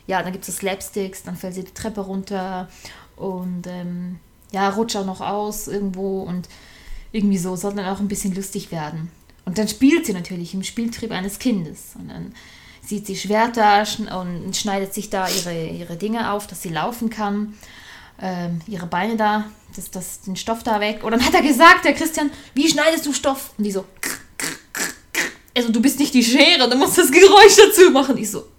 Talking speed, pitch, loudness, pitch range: 205 wpm, 205 Hz, -18 LUFS, 190-230 Hz